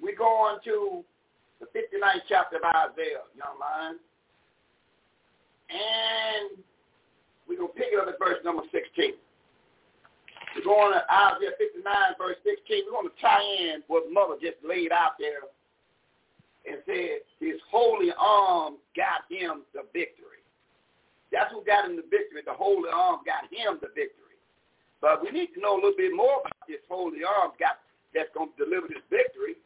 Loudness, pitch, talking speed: -27 LUFS, 370 Hz, 165 wpm